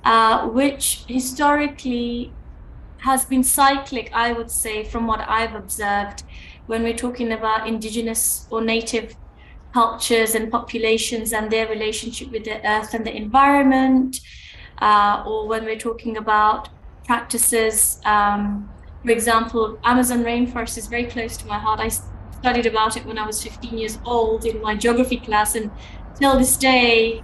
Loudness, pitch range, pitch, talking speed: -20 LUFS, 220-240 Hz, 230 Hz, 150 wpm